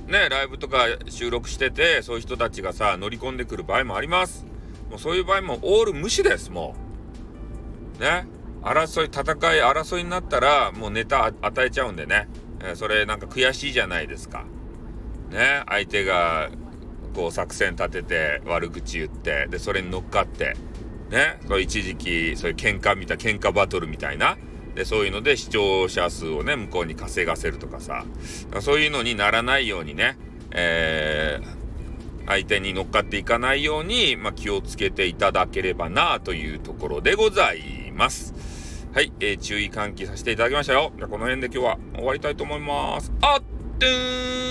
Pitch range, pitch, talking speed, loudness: 95-155 Hz, 115 Hz, 360 characters per minute, -23 LUFS